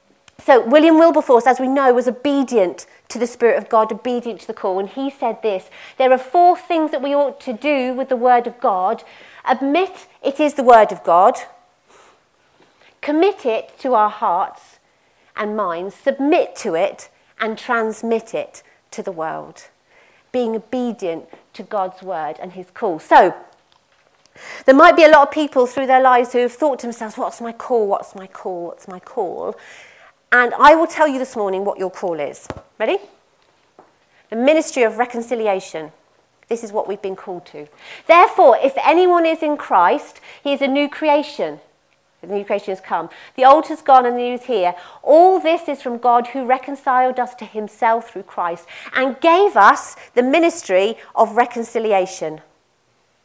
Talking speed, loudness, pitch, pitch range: 180 wpm, -16 LUFS, 245 Hz, 215-285 Hz